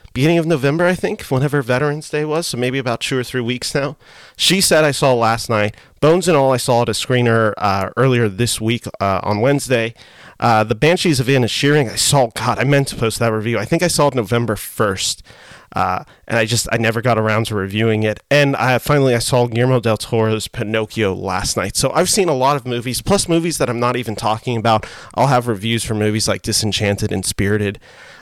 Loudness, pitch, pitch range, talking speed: -17 LUFS, 120 Hz, 110-140 Hz, 230 wpm